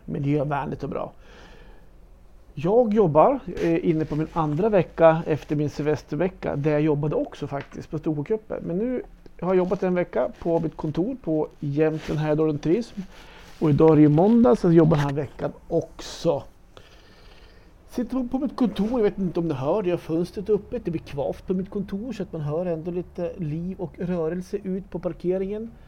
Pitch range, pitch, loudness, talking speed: 155-195 Hz, 170 Hz, -24 LUFS, 190 wpm